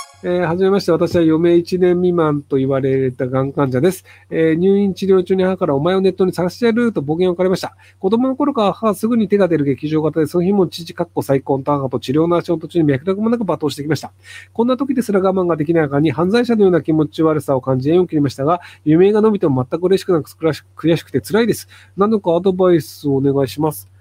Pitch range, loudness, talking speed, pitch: 145-190 Hz, -16 LUFS, 470 characters per minute, 170 Hz